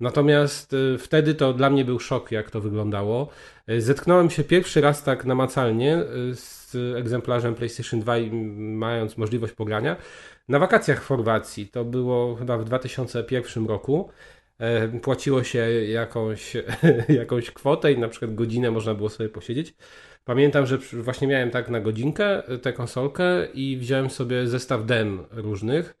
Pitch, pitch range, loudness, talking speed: 125 Hz, 115-135 Hz, -24 LUFS, 140 wpm